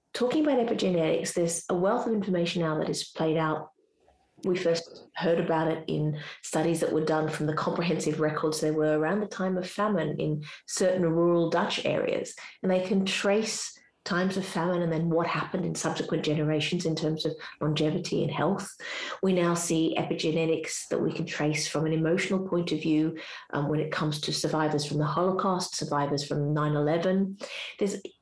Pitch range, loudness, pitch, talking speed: 155-185 Hz, -28 LUFS, 165 Hz, 185 wpm